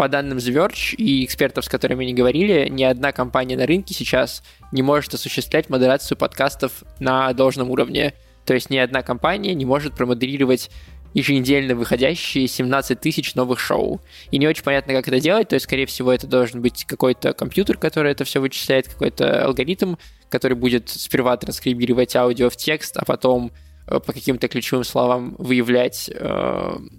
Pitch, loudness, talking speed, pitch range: 130 Hz, -20 LUFS, 160 wpm, 125-140 Hz